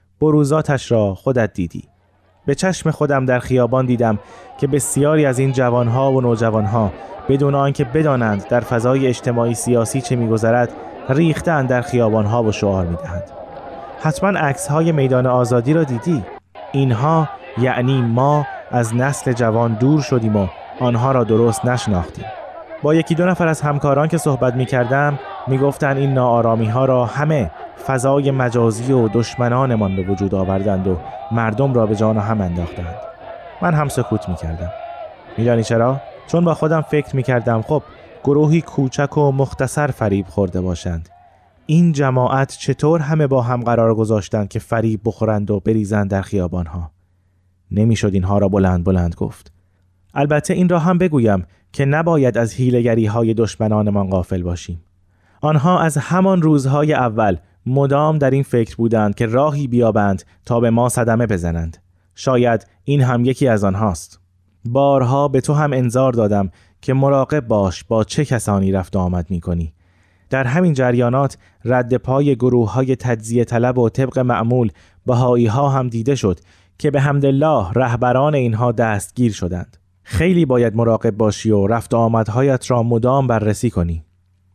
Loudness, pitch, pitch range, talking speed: -17 LUFS, 120 Hz, 105-140 Hz, 150 wpm